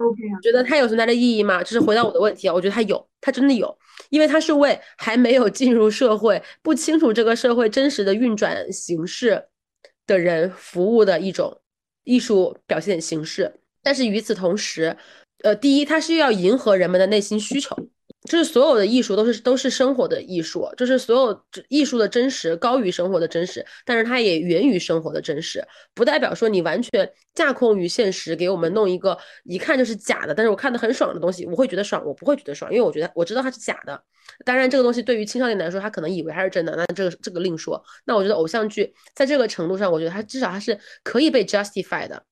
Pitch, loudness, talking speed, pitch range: 220 Hz, -20 LUFS, 355 characters per minute, 185-255 Hz